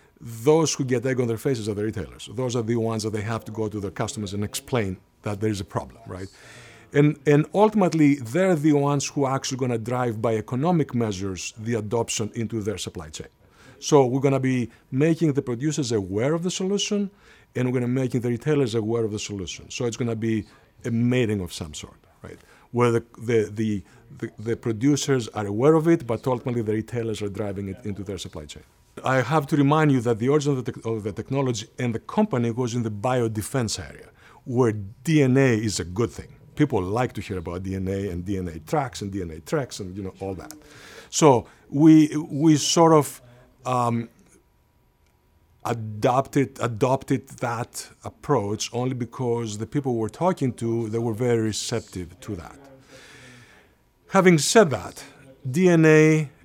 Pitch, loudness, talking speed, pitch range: 120 Hz, -23 LUFS, 190 wpm, 110-140 Hz